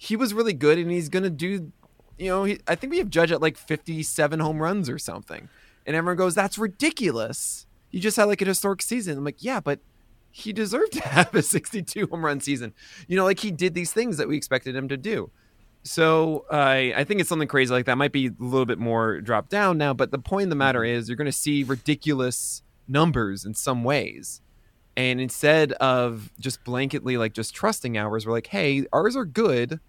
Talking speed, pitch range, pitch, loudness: 220 wpm, 125-185 Hz, 150 Hz, -24 LUFS